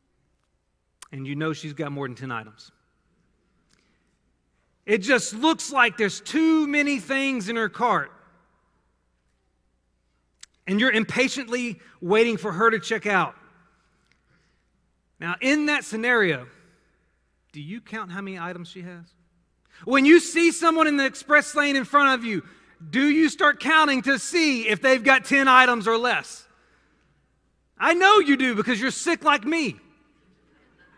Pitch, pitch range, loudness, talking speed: 240 Hz, 180-285 Hz, -21 LUFS, 145 wpm